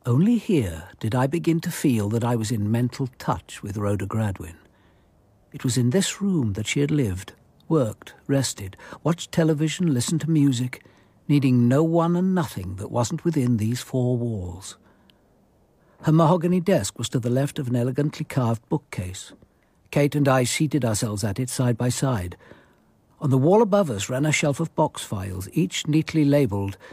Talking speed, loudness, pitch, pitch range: 175 wpm, -23 LUFS, 130 Hz, 110-155 Hz